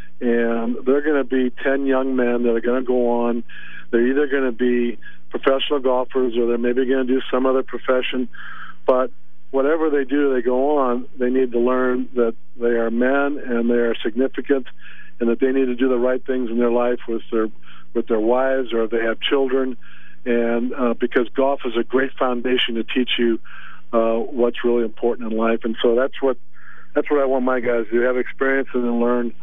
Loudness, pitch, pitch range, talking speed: -20 LUFS, 125 Hz, 120-130 Hz, 210 wpm